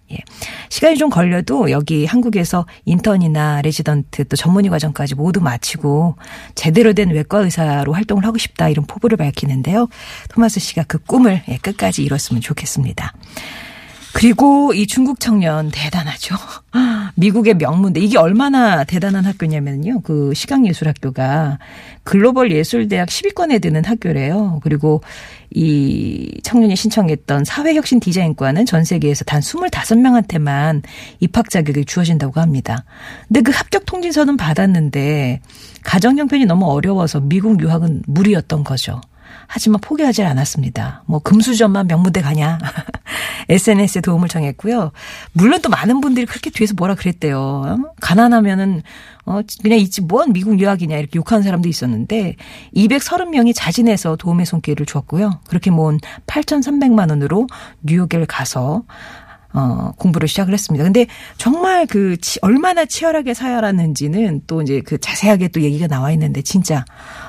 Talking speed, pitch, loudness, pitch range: 335 characters per minute, 180 Hz, -15 LUFS, 150-225 Hz